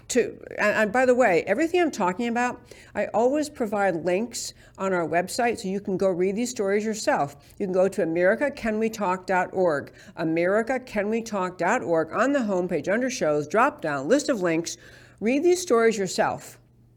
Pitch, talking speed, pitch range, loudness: 205 Hz, 155 wpm, 180-240 Hz, -24 LUFS